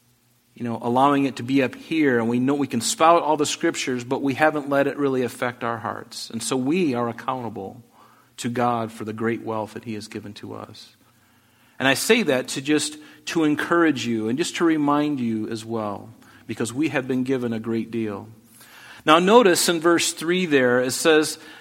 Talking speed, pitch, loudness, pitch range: 210 wpm, 125 Hz, -22 LUFS, 115-150 Hz